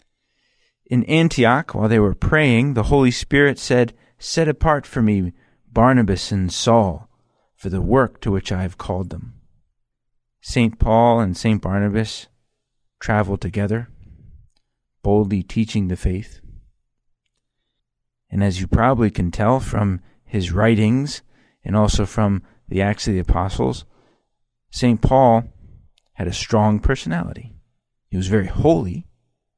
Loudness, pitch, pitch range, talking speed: -19 LUFS, 110 Hz, 95-120 Hz, 130 wpm